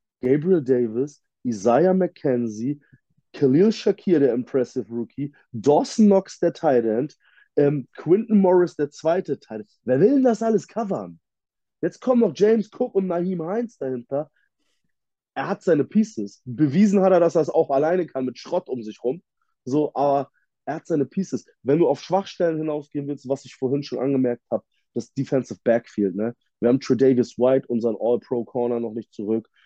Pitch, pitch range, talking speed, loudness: 140 Hz, 125-180 Hz, 170 wpm, -22 LUFS